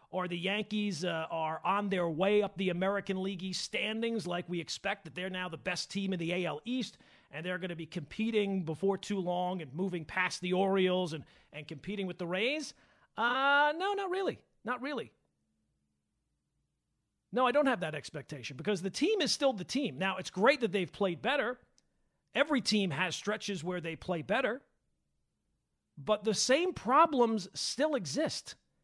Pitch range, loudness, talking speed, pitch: 175-220 Hz, -33 LUFS, 180 wpm, 190 Hz